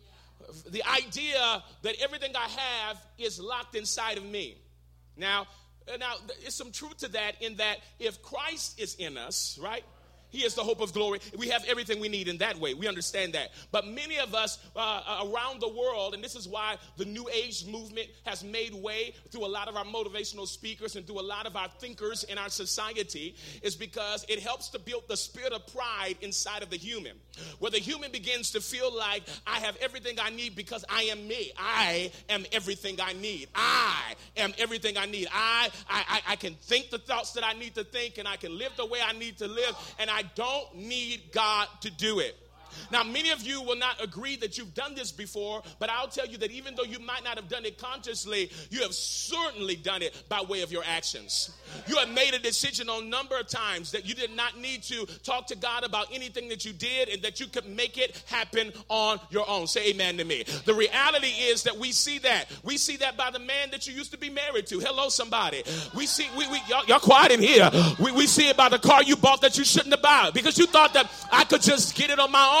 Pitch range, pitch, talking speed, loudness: 205-255 Hz, 225 Hz, 230 wpm, -27 LUFS